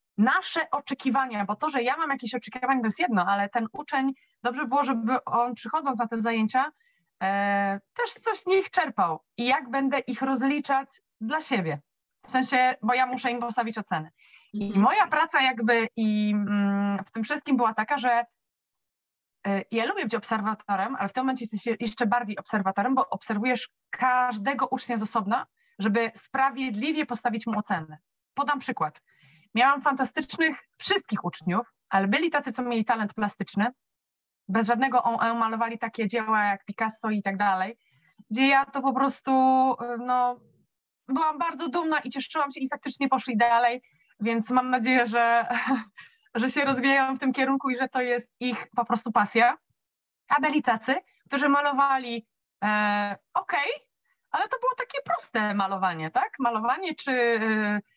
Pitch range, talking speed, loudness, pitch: 215-270 Hz, 165 wpm, -26 LUFS, 245 Hz